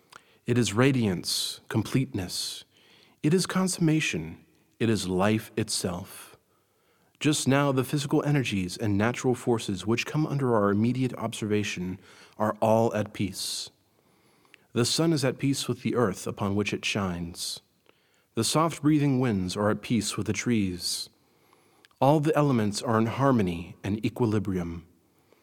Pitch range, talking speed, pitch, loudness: 100-130 Hz, 140 wpm, 115 Hz, -27 LUFS